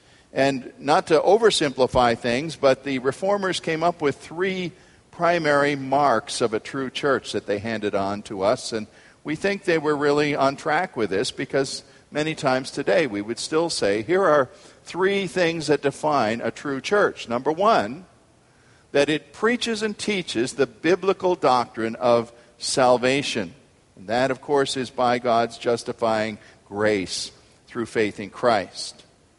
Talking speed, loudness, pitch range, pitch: 155 wpm, -23 LUFS, 120-165 Hz, 140 Hz